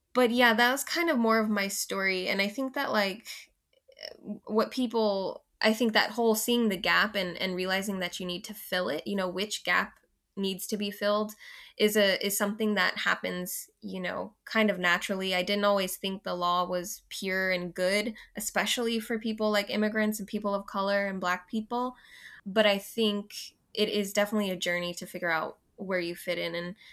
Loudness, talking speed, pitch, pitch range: -29 LUFS, 200 wpm, 205 Hz, 185-220 Hz